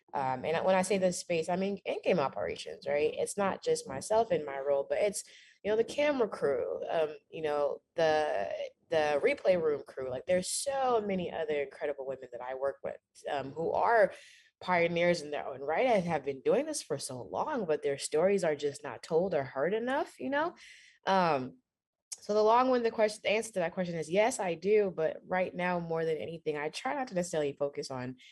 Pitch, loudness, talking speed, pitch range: 185 Hz, -32 LUFS, 215 wpm, 150-245 Hz